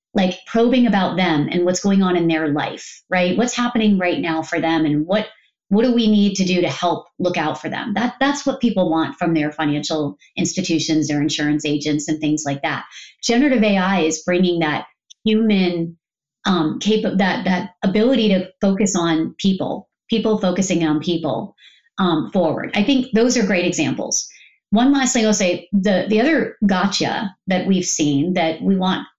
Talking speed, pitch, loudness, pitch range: 185 wpm, 185 Hz, -18 LUFS, 160-215 Hz